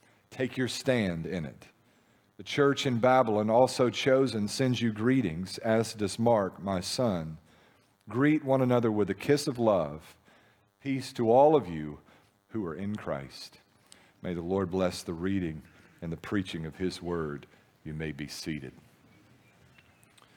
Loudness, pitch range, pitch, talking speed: -29 LUFS, 85-125 Hz, 105 Hz, 155 wpm